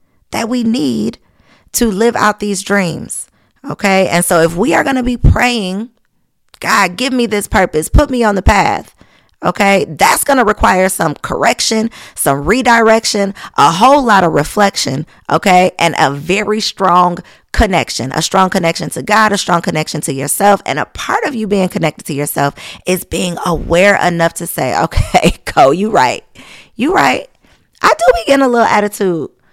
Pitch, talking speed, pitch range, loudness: 195 Hz, 170 wpm, 170-220 Hz, -12 LUFS